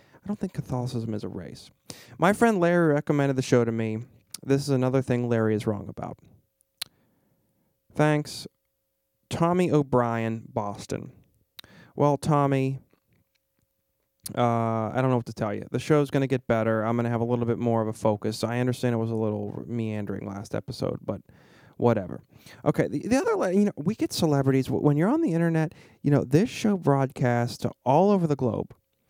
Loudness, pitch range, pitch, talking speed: -26 LUFS, 110-150 Hz, 125 Hz, 180 wpm